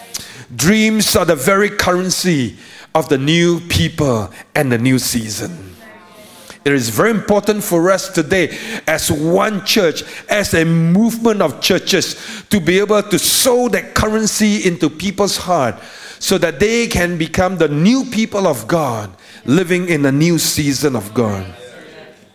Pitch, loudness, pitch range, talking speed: 175 Hz, -15 LUFS, 150-205 Hz, 150 wpm